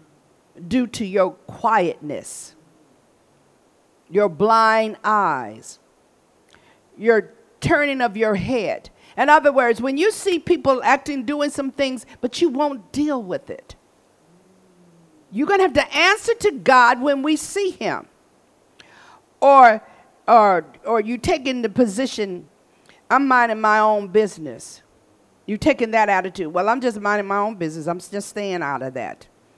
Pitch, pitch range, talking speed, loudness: 240 Hz, 210-290 Hz, 140 wpm, -19 LUFS